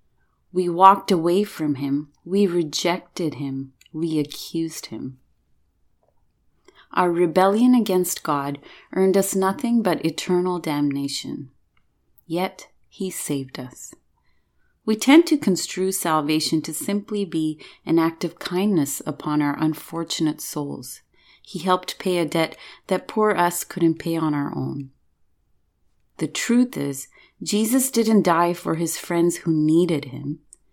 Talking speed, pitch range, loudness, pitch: 130 wpm, 145-185 Hz, -22 LUFS, 165 Hz